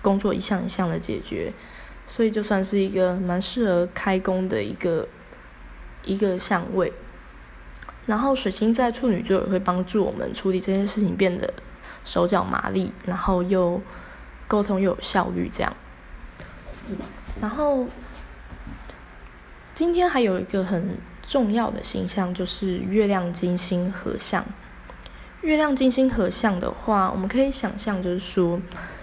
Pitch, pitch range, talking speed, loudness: 190 Hz, 180-210 Hz, 215 characters per minute, -23 LUFS